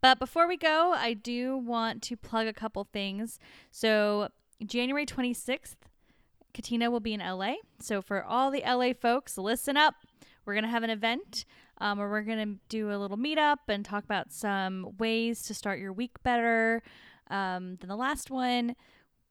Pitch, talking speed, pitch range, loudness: 230 Hz, 180 wpm, 205-250 Hz, -30 LUFS